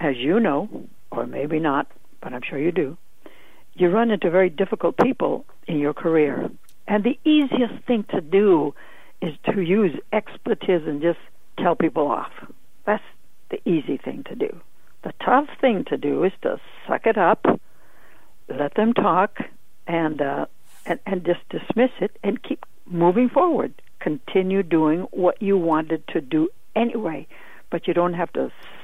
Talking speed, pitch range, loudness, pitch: 160 wpm, 170-225 Hz, -22 LUFS, 190 Hz